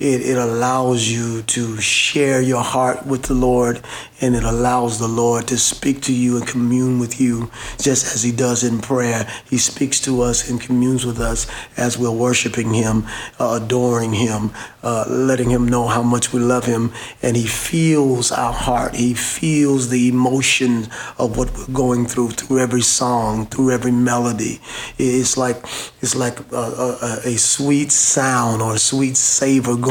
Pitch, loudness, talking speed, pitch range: 125 Hz, -17 LUFS, 175 wpm, 120-130 Hz